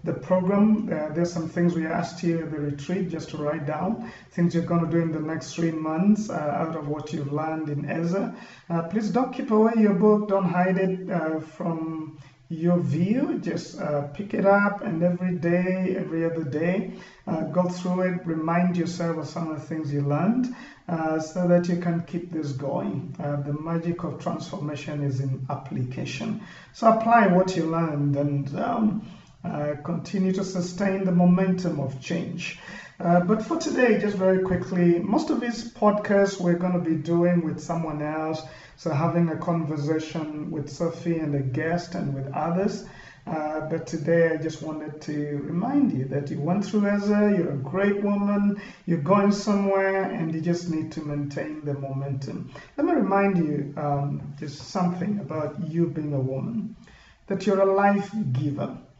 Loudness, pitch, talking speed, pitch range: -25 LUFS, 170 Hz, 185 wpm, 155-195 Hz